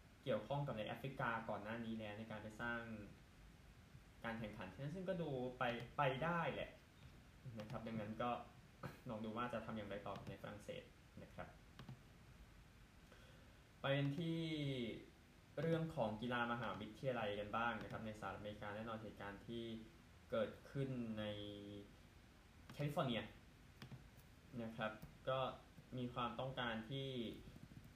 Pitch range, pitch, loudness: 105-130 Hz, 115 Hz, -47 LUFS